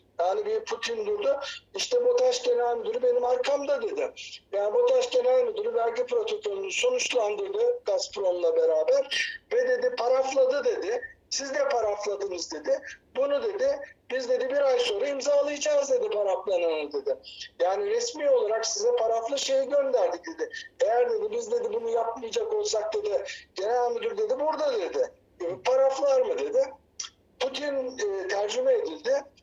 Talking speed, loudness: 140 wpm, -27 LUFS